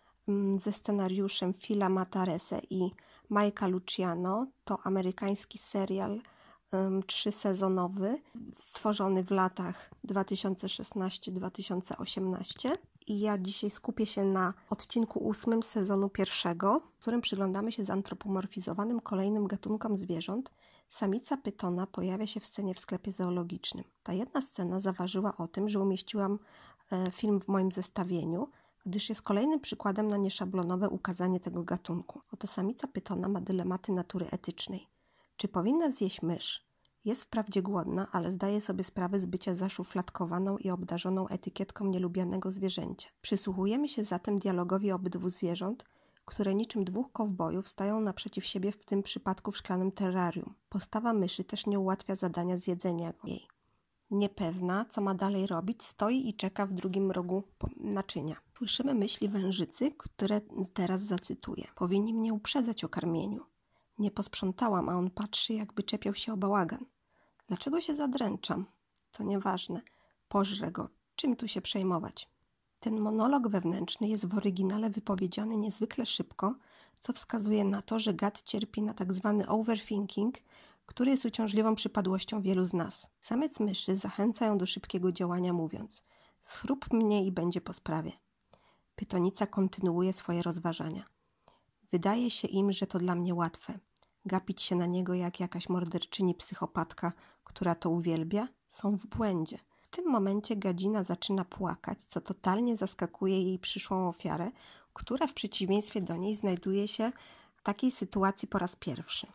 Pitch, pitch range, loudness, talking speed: 195 Hz, 185-215 Hz, -33 LUFS, 140 wpm